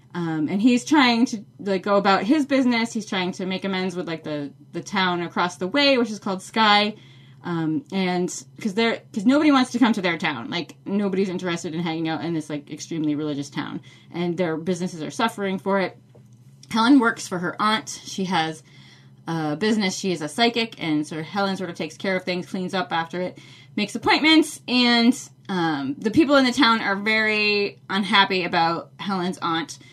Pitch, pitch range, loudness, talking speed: 185 Hz, 160-220 Hz, -22 LUFS, 195 wpm